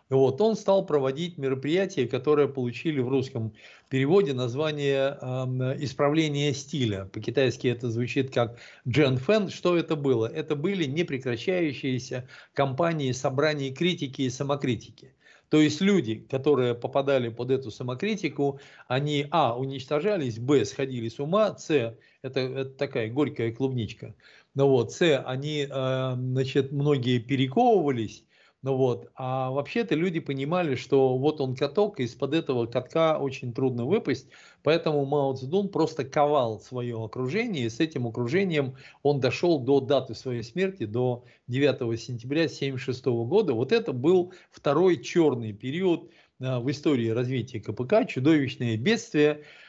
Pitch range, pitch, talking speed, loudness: 125-150 Hz, 135 Hz, 135 wpm, -26 LUFS